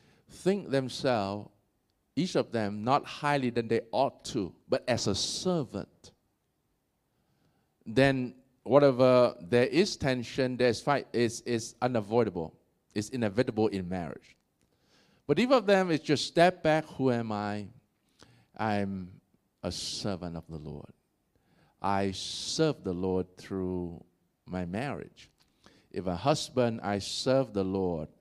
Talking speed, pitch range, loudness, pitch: 125 wpm, 95-135 Hz, -30 LUFS, 115 Hz